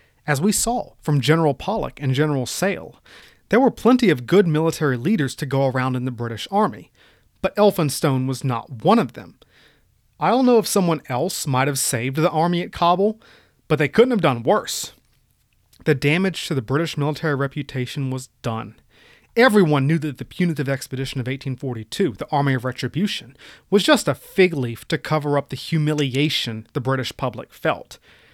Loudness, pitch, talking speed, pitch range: -21 LUFS, 145 Hz, 180 wpm, 130-170 Hz